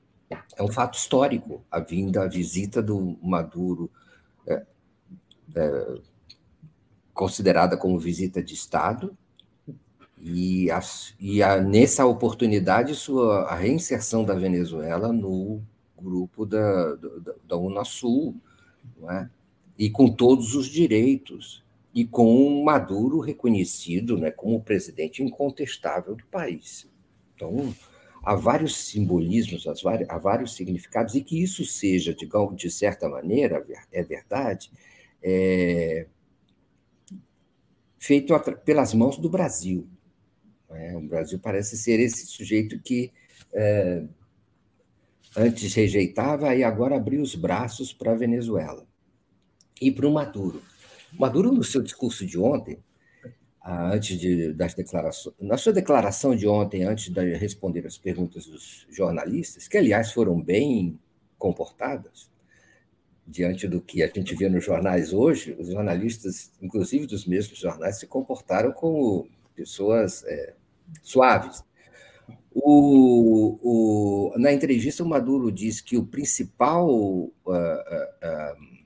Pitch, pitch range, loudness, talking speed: 105 Hz, 90-130 Hz, -24 LUFS, 120 wpm